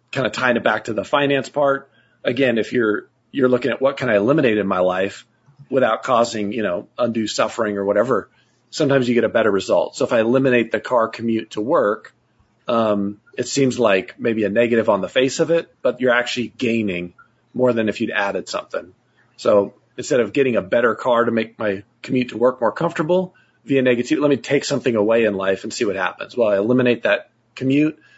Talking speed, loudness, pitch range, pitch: 215 wpm, -19 LUFS, 110-135 Hz, 120 Hz